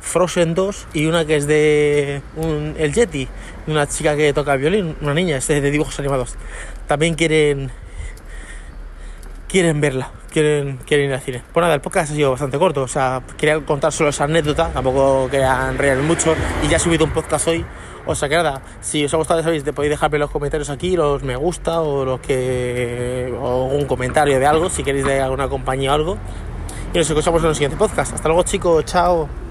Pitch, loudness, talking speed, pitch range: 150 Hz, -18 LUFS, 200 wpm, 135-160 Hz